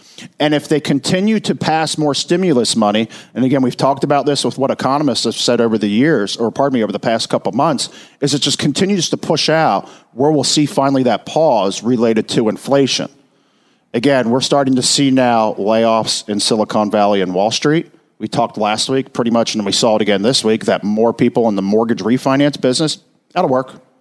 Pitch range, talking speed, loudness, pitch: 110-145 Hz, 210 wpm, -15 LUFS, 130 Hz